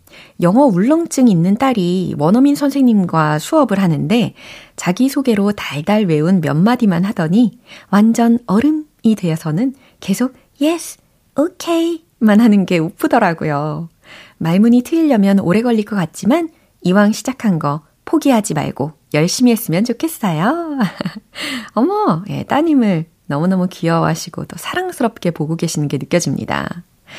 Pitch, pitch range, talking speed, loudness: 210 Hz, 170-265 Hz, 295 characters per minute, -15 LUFS